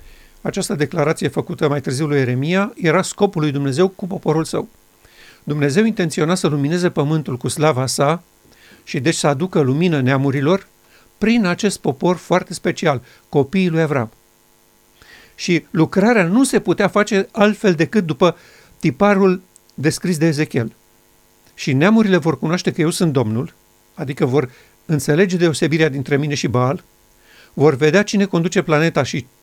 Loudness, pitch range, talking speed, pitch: -17 LUFS, 140-185 Hz, 145 wpm, 160 Hz